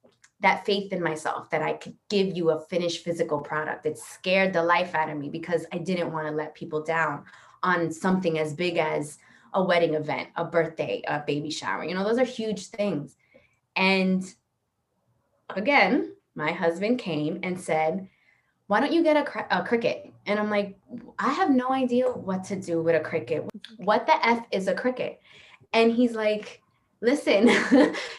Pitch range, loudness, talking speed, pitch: 165-220 Hz, -26 LUFS, 180 wpm, 185 Hz